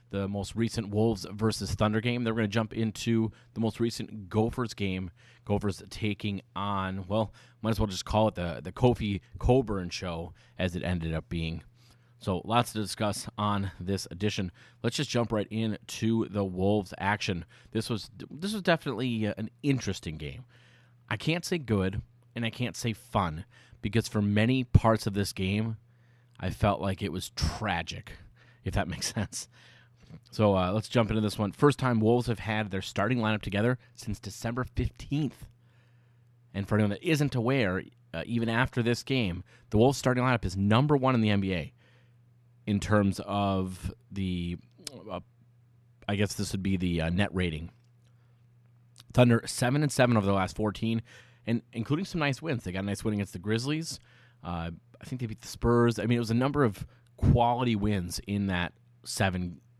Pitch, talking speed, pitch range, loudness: 110 Hz, 180 wpm, 100-120 Hz, -30 LUFS